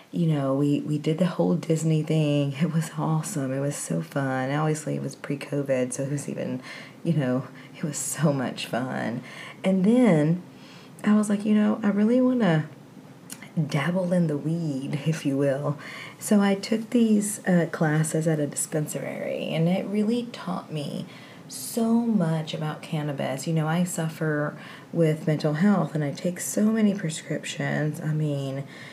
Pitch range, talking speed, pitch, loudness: 145-185 Hz, 170 wpm, 160 Hz, -25 LUFS